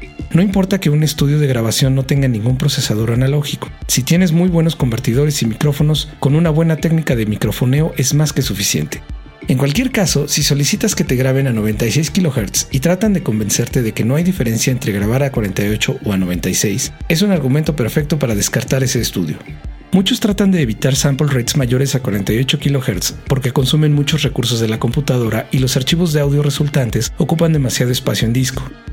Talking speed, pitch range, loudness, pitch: 190 wpm, 120-155 Hz, -15 LUFS, 140 Hz